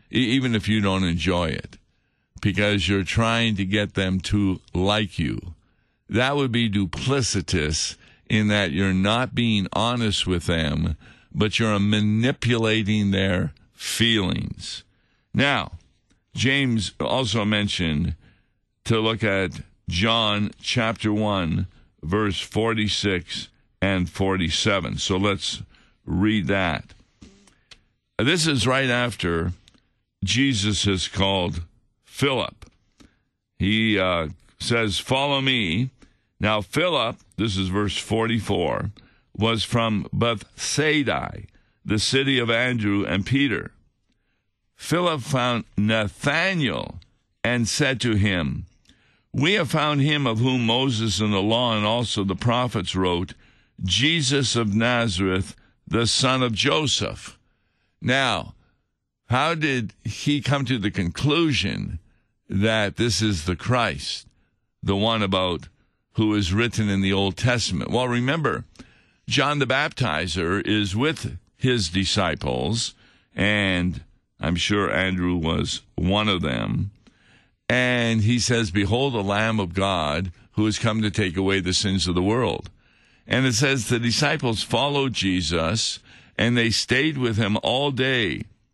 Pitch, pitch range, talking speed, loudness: 105 Hz, 95-120 Hz, 120 wpm, -22 LUFS